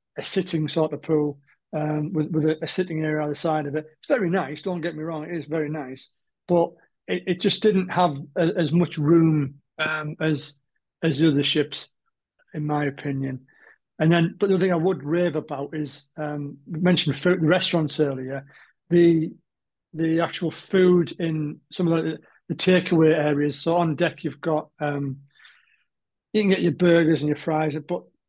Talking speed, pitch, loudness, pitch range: 195 wpm, 160 Hz, -23 LUFS, 150-170 Hz